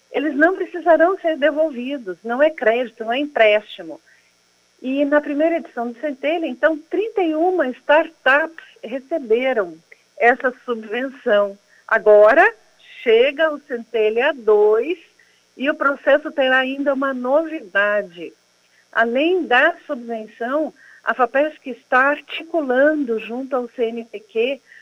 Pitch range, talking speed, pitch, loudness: 235-315 Hz, 110 wpm, 275 Hz, -18 LUFS